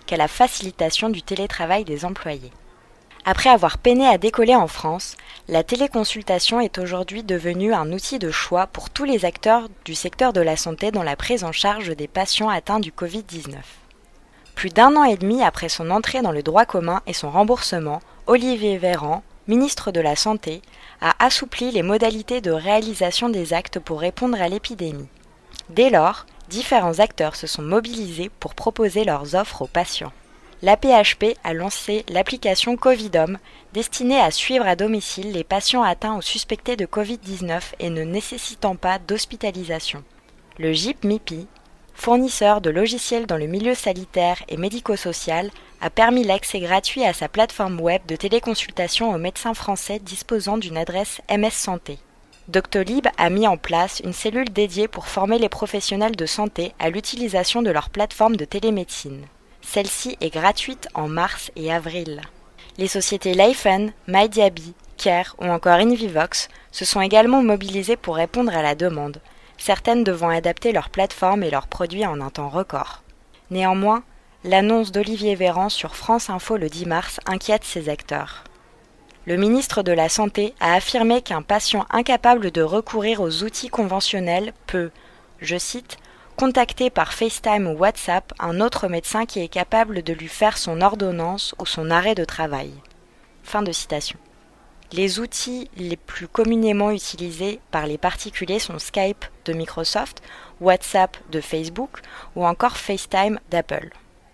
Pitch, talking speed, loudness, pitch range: 195 Hz, 155 wpm, -21 LUFS, 170-220 Hz